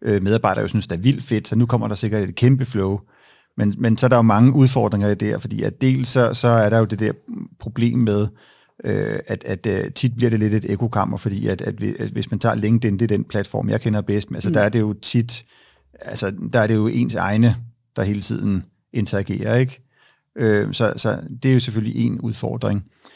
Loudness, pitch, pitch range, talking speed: -20 LUFS, 110 Hz, 105-120 Hz, 225 wpm